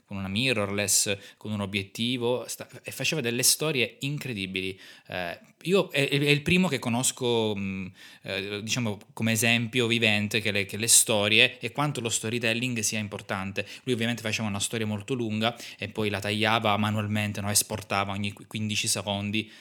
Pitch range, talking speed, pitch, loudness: 105-120 Hz, 150 wpm, 110 Hz, -26 LUFS